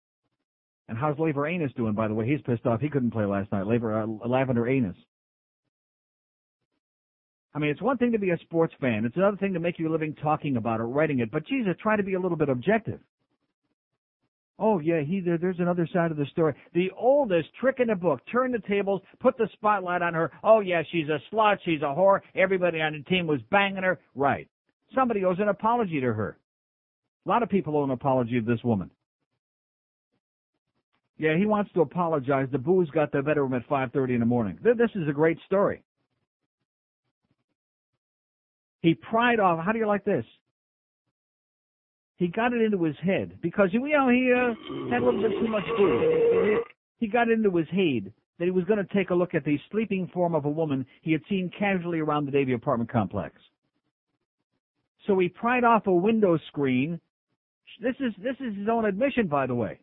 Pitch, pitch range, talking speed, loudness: 170 Hz, 140-205 Hz, 200 wpm, -26 LUFS